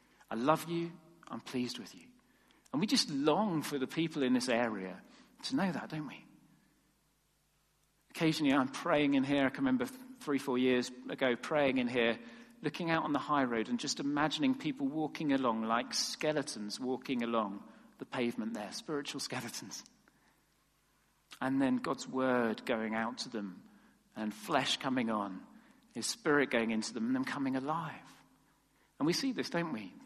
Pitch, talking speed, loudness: 145 Hz, 170 wpm, -34 LUFS